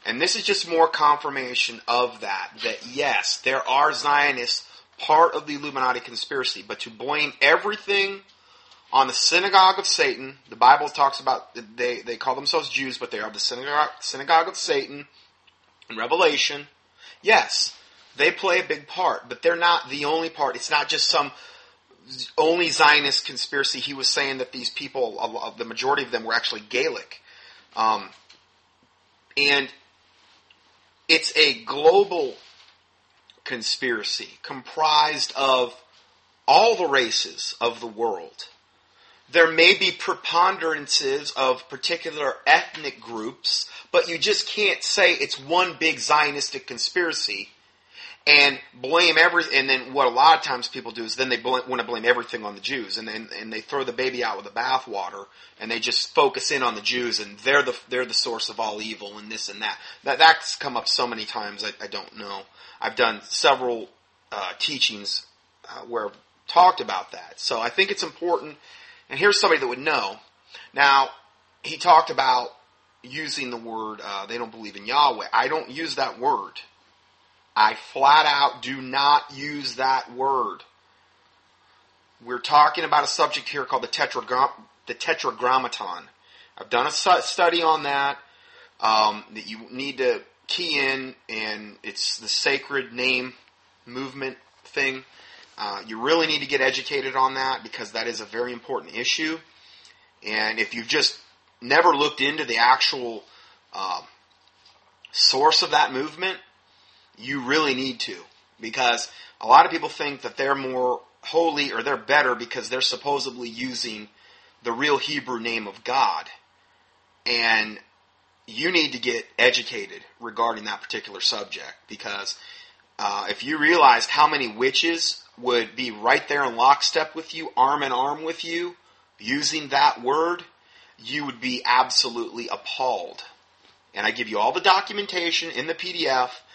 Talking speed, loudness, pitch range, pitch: 160 wpm, -22 LUFS, 125-170 Hz, 140 Hz